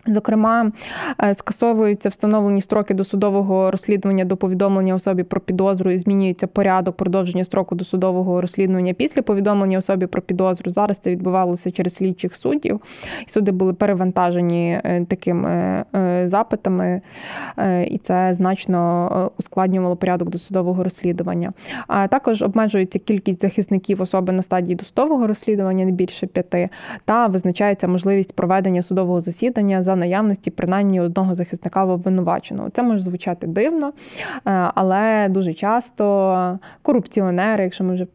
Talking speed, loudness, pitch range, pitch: 125 wpm, -19 LUFS, 180-205 Hz, 190 Hz